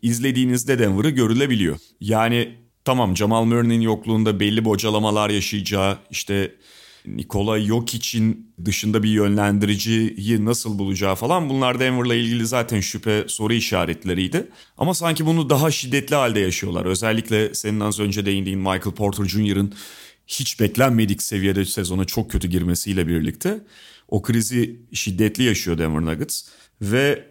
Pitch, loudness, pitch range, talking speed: 110 Hz, -21 LUFS, 100-120 Hz, 125 wpm